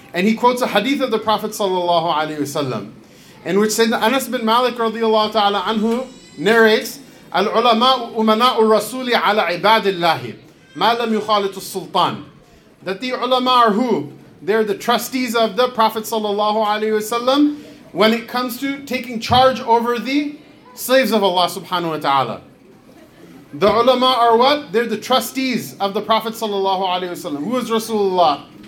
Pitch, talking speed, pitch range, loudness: 225 Hz, 145 wpm, 200-245 Hz, -17 LUFS